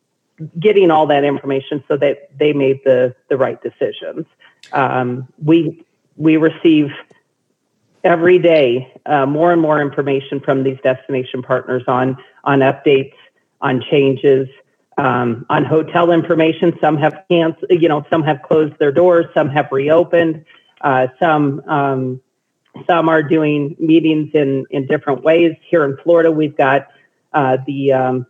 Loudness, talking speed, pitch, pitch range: -15 LUFS, 145 wpm, 150 Hz, 135-165 Hz